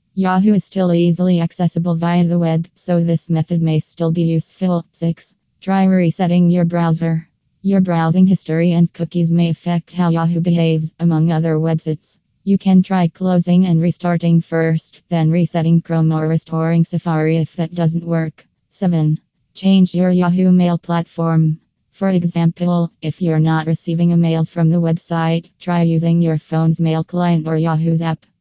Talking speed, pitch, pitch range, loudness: 160 wpm, 170 Hz, 160-175 Hz, -16 LUFS